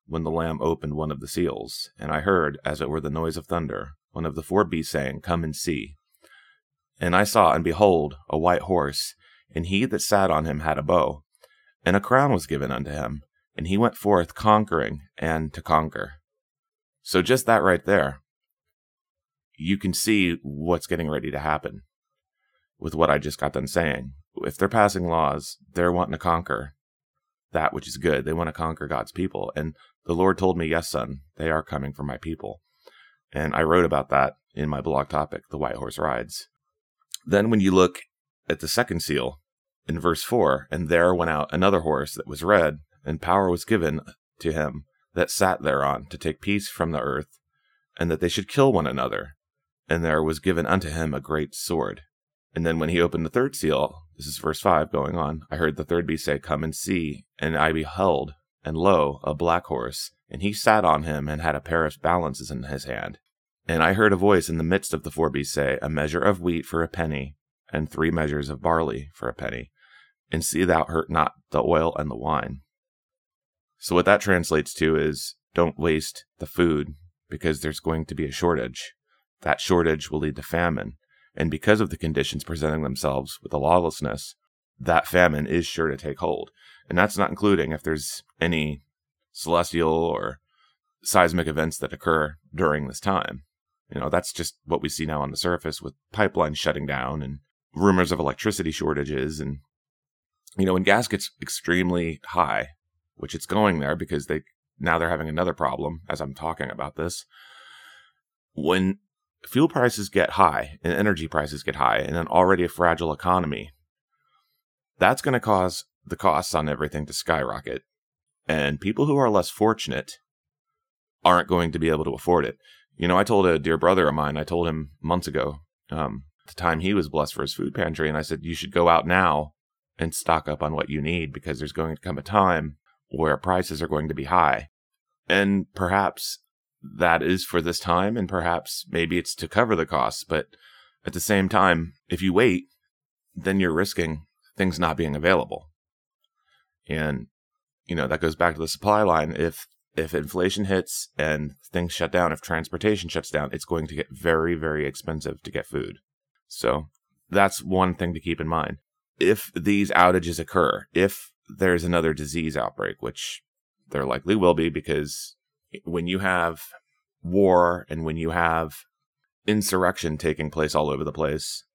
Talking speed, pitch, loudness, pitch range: 190 wpm, 80 Hz, -24 LUFS, 75-90 Hz